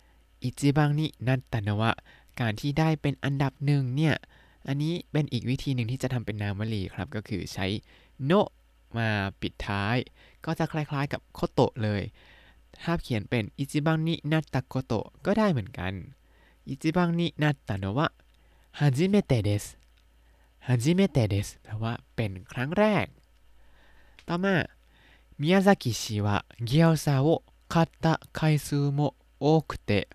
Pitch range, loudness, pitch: 105-155 Hz, -28 LUFS, 130 Hz